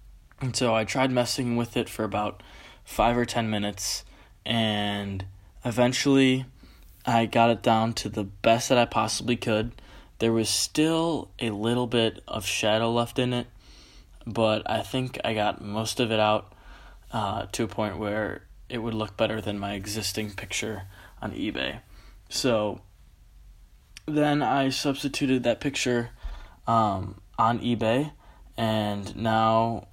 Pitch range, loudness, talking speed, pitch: 100-120 Hz, -26 LUFS, 145 wpm, 110 Hz